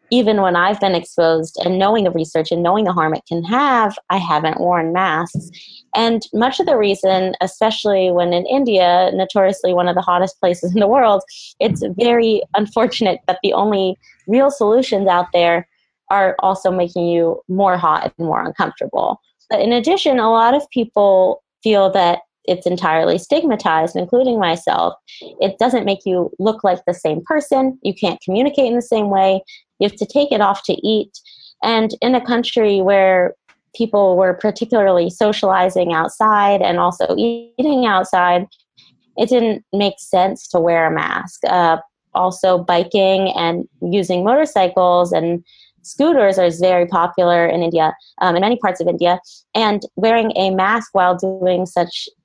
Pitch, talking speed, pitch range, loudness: 190 Hz, 165 wpm, 180-225 Hz, -16 LUFS